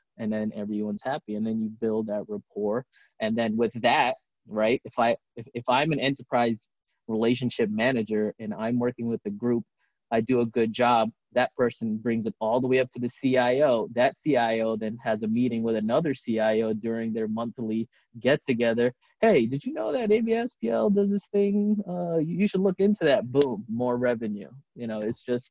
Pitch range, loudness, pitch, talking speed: 110-140 Hz, -26 LUFS, 120 Hz, 195 wpm